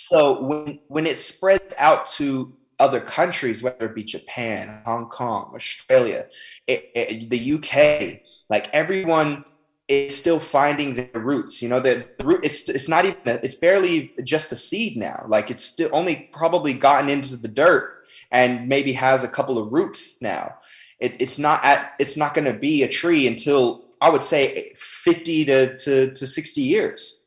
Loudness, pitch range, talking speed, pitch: -20 LUFS, 125-170 Hz, 180 wpm, 145 Hz